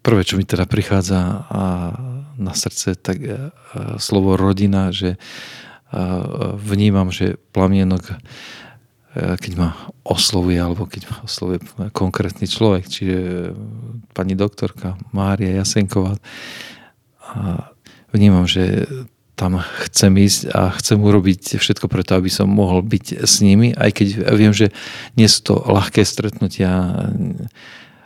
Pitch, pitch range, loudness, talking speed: 100 Hz, 95-105 Hz, -17 LUFS, 115 wpm